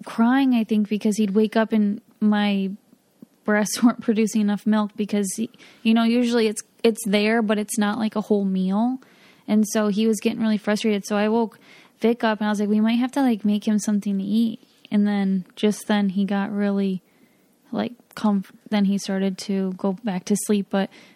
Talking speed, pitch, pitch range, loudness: 205 wpm, 215 Hz, 205-230 Hz, -22 LUFS